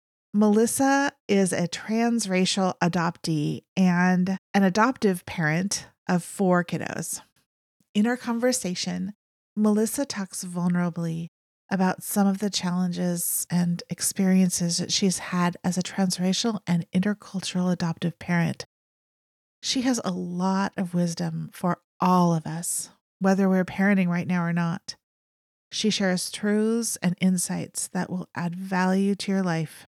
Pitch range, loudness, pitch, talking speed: 175-200 Hz, -25 LUFS, 185 Hz, 130 wpm